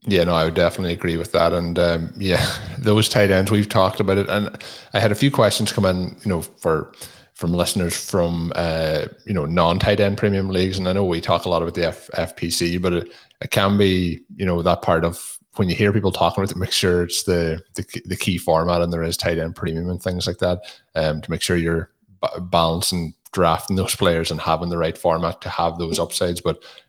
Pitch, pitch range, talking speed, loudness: 90 Hz, 85-100 Hz, 230 wpm, -20 LUFS